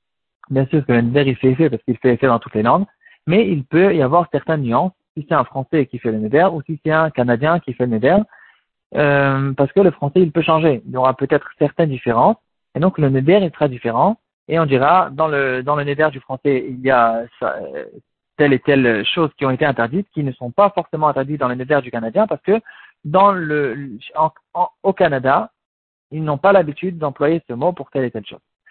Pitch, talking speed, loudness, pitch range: 145 Hz, 230 wpm, -17 LUFS, 130-165 Hz